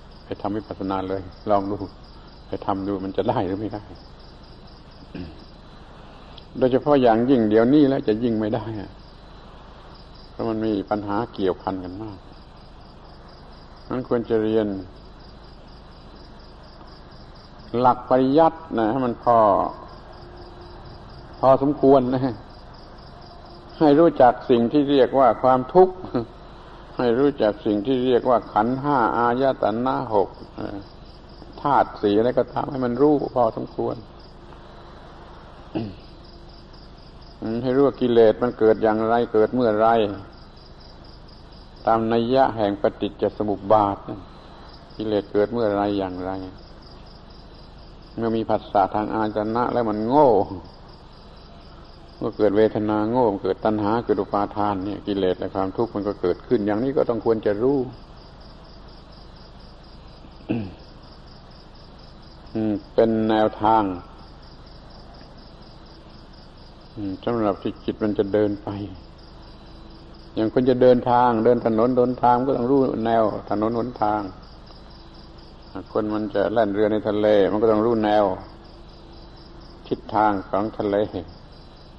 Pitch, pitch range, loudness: 105 Hz, 100-120 Hz, -21 LUFS